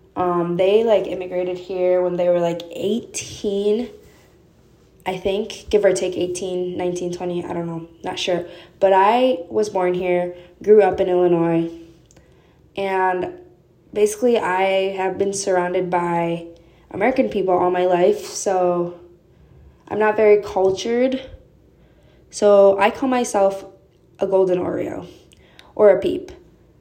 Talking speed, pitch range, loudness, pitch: 130 wpm, 180-205 Hz, -19 LUFS, 185 Hz